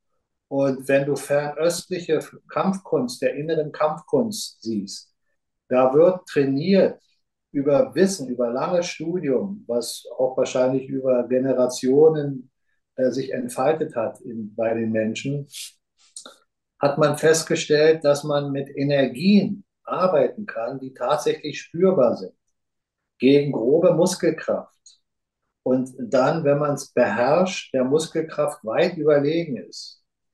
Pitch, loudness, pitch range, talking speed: 145 Hz, -22 LUFS, 130-165 Hz, 115 wpm